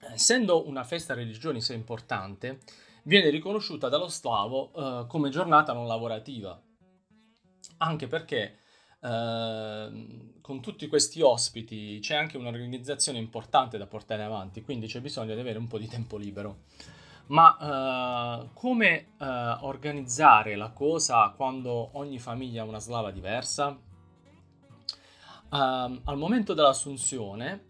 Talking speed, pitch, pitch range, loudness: 120 wpm, 130 Hz, 115-150 Hz, -27 LUFS